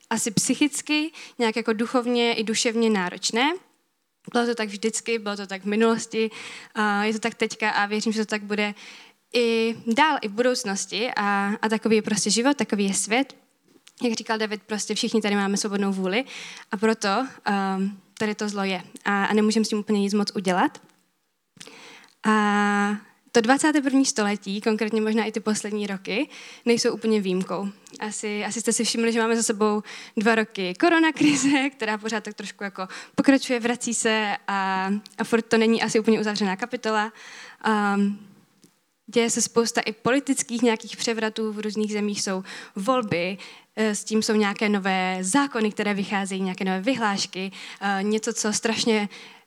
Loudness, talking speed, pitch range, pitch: -24 LUFS, 160 wpm, 205-235 Hz, 220 Hz